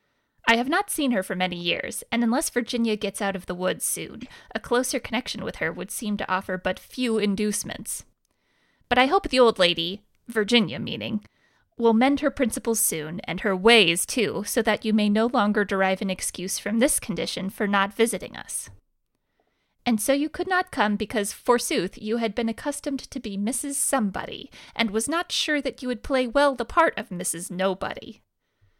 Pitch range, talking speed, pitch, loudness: 195-255 Hz, 190 wpm, 220 Hz, -24 LUFS